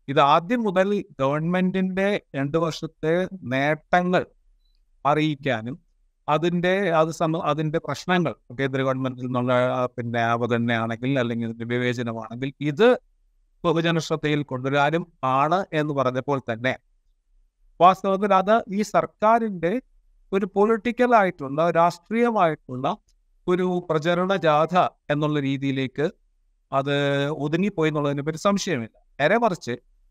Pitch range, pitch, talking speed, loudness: 130-180 Hz, 150 Hz, 90 wpm, -23 LUFS